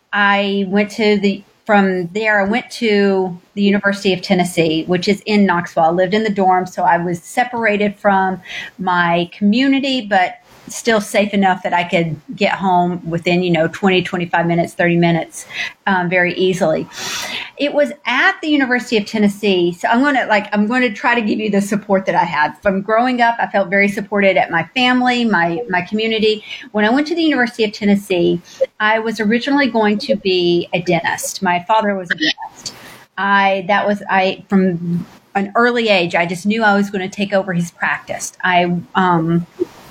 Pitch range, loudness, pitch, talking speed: 180-220 Hz, -16 LUFS, 200 Hz, 190 wpm